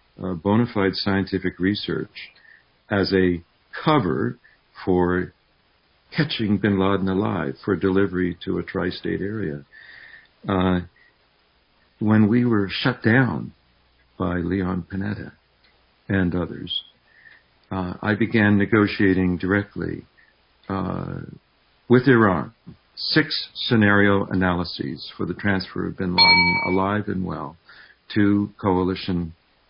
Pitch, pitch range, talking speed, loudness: 95 Hz, 90-105 Hz, 105 wpm, -22 LUFS